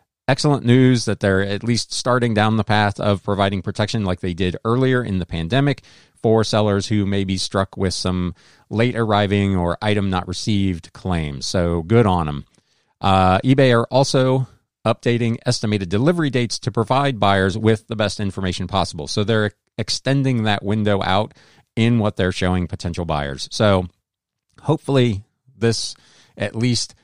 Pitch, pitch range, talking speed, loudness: 105 Hz, 95-120 Hz, 160 wpm, -19 LUFS